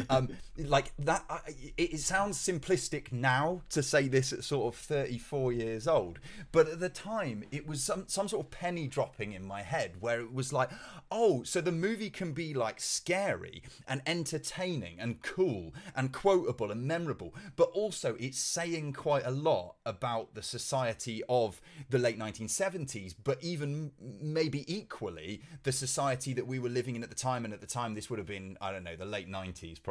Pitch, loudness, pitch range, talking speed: 140 Hz, -34 LUFS, 120-165 Hz, 190 wpm